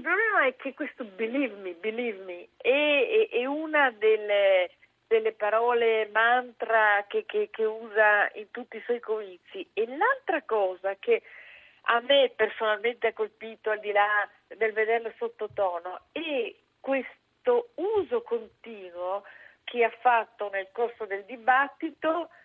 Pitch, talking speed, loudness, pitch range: 230 Hz, 135 wpm, -27 LUFS, 215-295 Hz